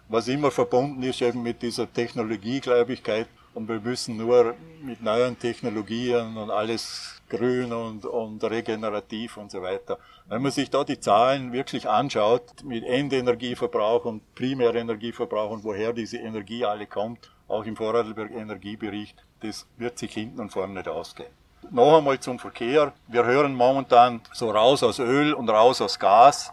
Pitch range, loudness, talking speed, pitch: 110-125 Hz, -24 LUFS, 155 wpm, 120 Hz